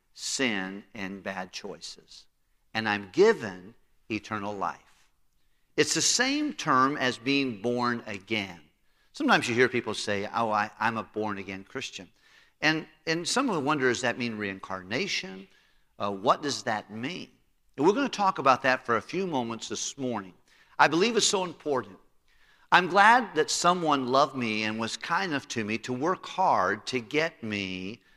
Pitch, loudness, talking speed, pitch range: 115 Hz, -27 LUFS, 170 wpm, 100-145 Hz